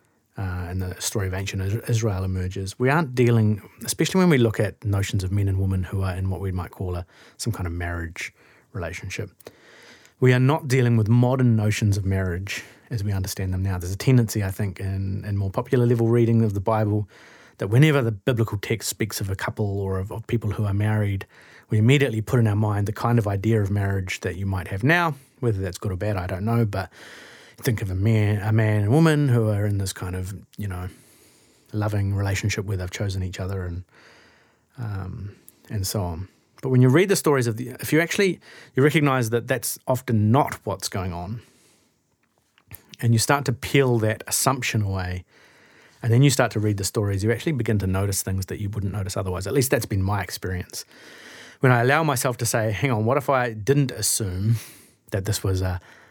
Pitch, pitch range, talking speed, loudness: 105 Hz, 95-120 Hz, 215 wpm, -23 LUFS